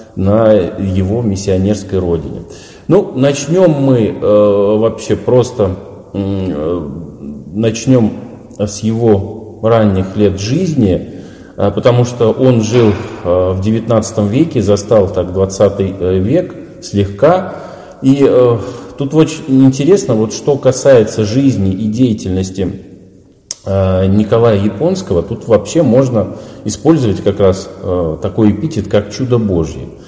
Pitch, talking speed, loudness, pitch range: 105 Hz, 115 wpm, -12 LUFS, 95-120 Hz